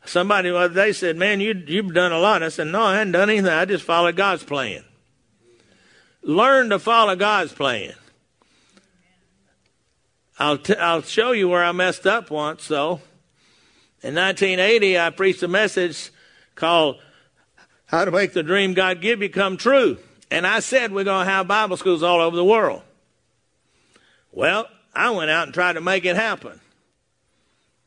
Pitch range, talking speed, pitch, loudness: 170-200 Hz, 165 wpm, 185 Hz, -19 LUFS